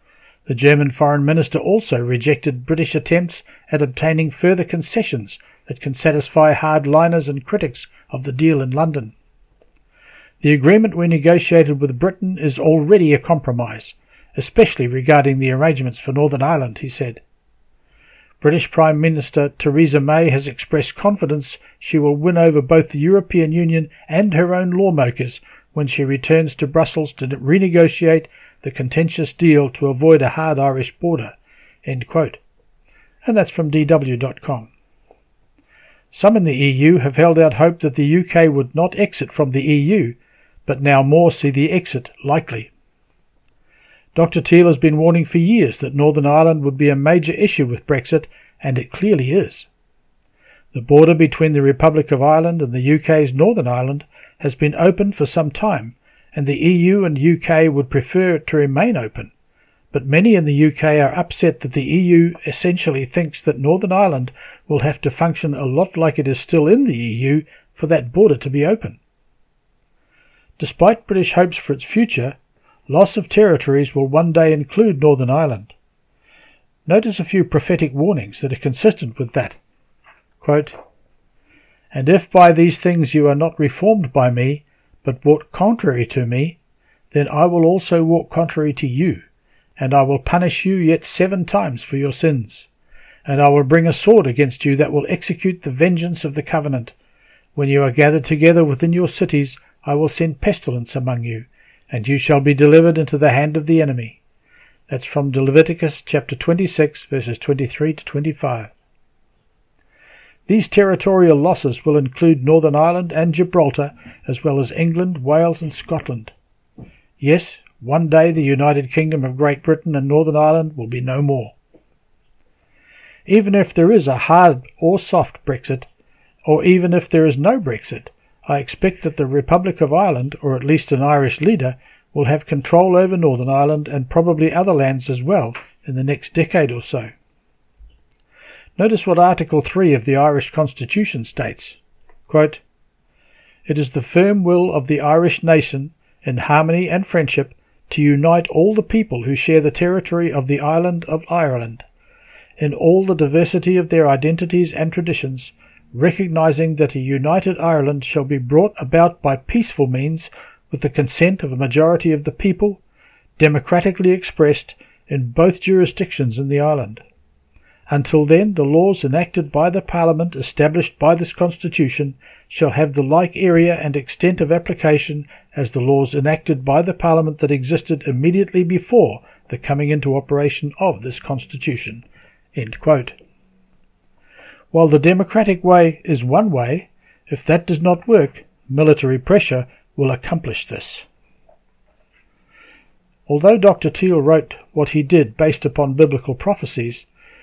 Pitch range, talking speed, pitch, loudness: 140-170 Hz, 160 wpm, 155 Hz, -16 LUFS